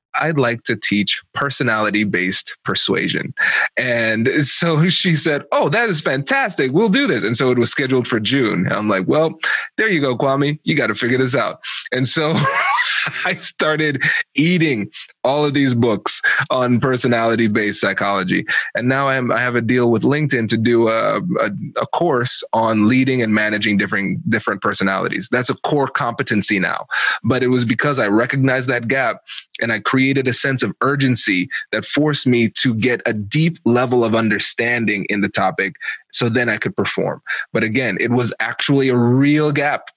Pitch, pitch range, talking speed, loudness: 125 Hz, 115-140 Hz, 180 wpm, -17 LUFS